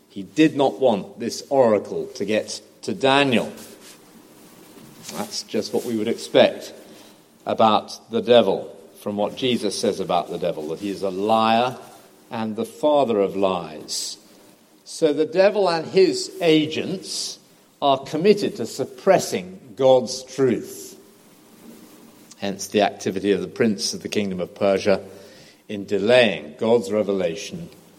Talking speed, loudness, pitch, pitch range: 135 wpm, -21 LUFS, 110 Hz, 100-145 Hz